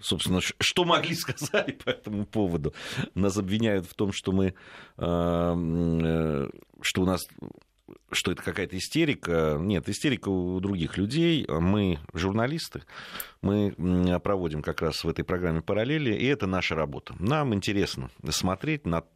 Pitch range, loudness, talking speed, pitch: 85-105 Hz, -28 LUFS, 140 wpm, 95 Hz